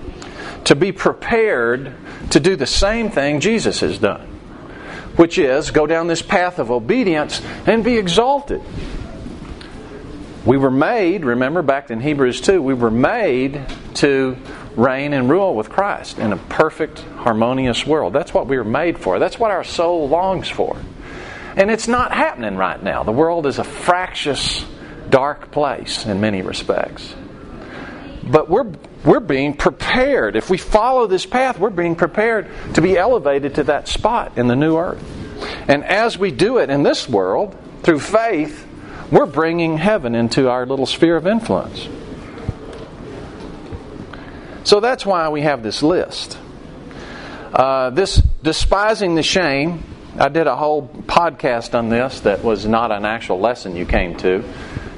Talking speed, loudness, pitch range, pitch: 155 wpm, -17 LUFS, 130-190 Hz, 150 Hz